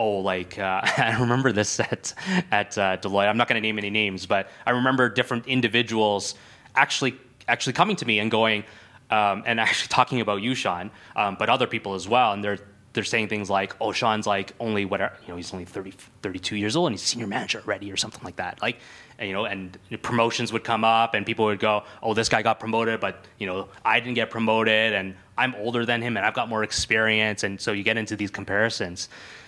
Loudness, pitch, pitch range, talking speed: -24 LUFS, 110 Hz, 100-120 Hz, 230 wpm